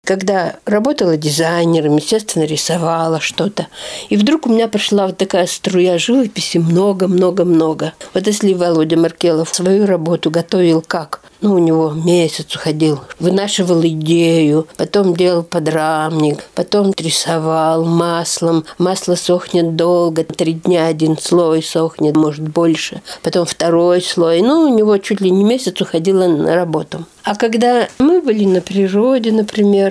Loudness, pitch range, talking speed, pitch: -14 LUFS, 165-195 Hz, 135 wpm, 175 Hz